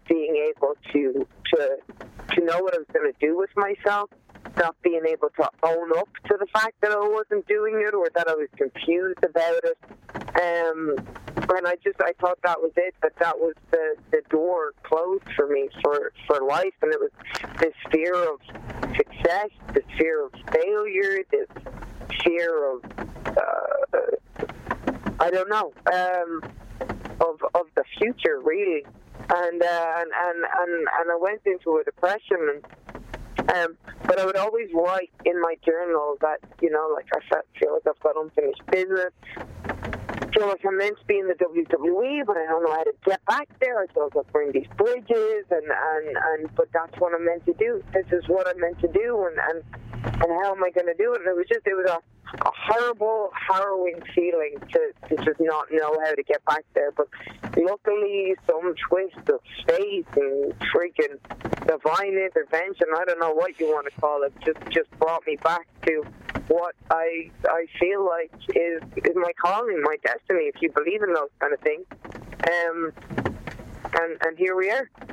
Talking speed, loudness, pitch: 185 wpm, -24 LUFS, 185 Hz